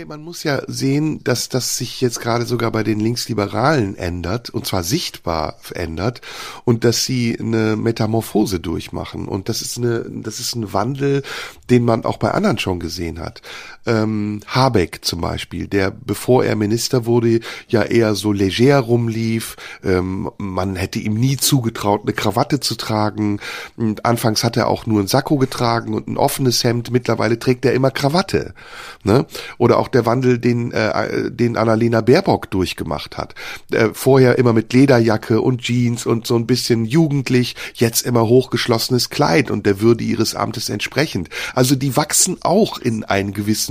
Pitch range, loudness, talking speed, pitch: 105-125 Hz, -18 LUFS, 160 wpm, 115 Hz